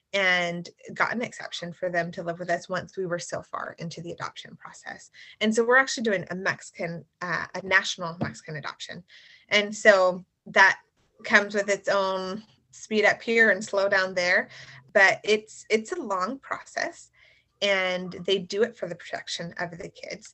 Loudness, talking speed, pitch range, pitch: -25 LUFS, 180 wpm, 180-210 Hz, 190 Hz